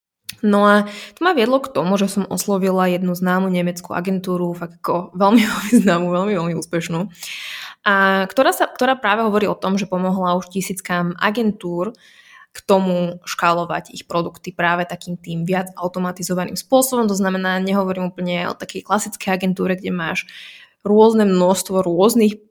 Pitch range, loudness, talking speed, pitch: 180-205 Hz, -18 LUFS, 155 wpm, 190 Hz